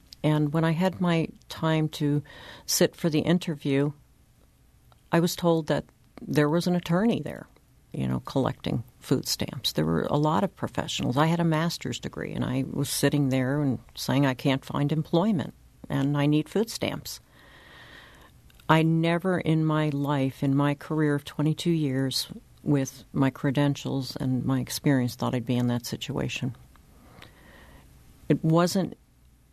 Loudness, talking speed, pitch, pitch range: -26 LUFS, 155 wpm, 145 Hz, 135-165 Hz